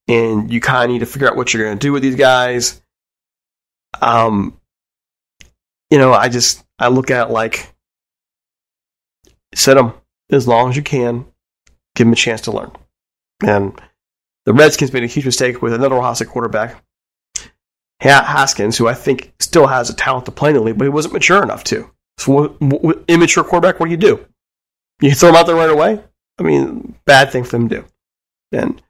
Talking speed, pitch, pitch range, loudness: 195 wpm, 120 Hz, 110-140 Hz, -13 LUFS